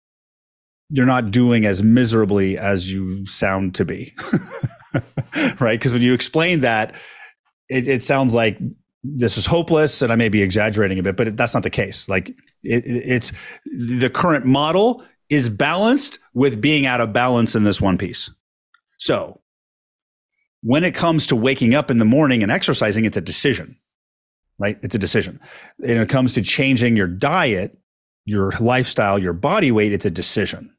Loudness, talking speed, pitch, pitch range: -18 LUFS, 170 wpm, 115 Hz, 100-130 Hz